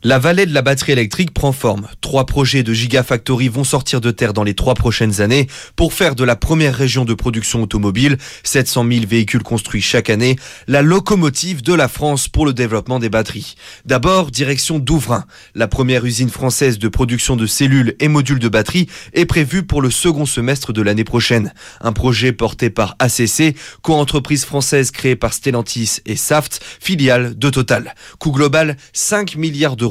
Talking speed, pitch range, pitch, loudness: 180 wpm, 120-145 Hz, 130 Hz, -15 LUFS